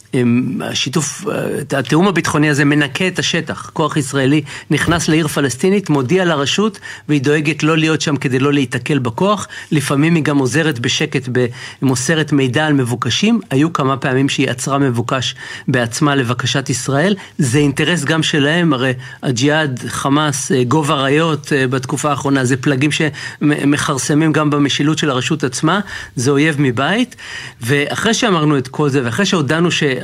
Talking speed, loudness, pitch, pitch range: 140 wpm, -15 LUFS, 145 Hz, 135-155 Hz